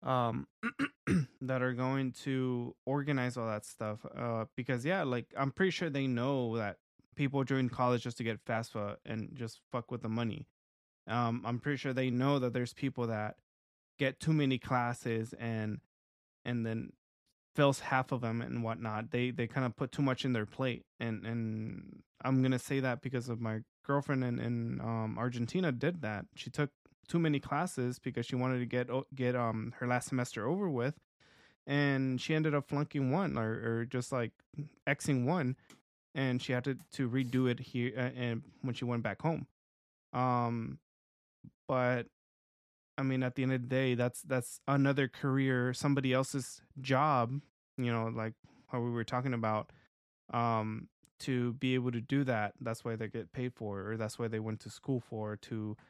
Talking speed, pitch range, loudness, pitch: 185 wpm, 115-135 Hz, -35 LUFS, 125 Hz